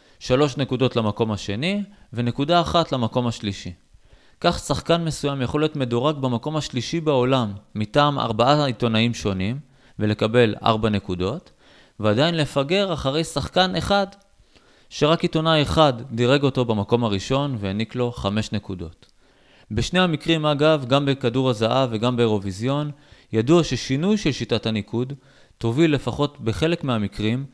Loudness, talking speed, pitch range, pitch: -22 LUFS, 125 wpm, 110-150 Hz, 130 Hz